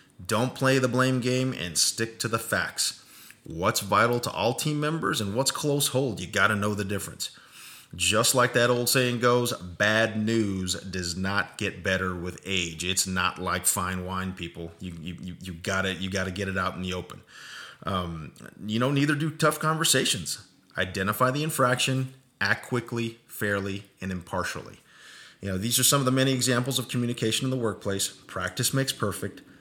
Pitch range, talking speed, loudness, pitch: 95-130 Hz, 185 wpm, -26 LUFS, 105 Hz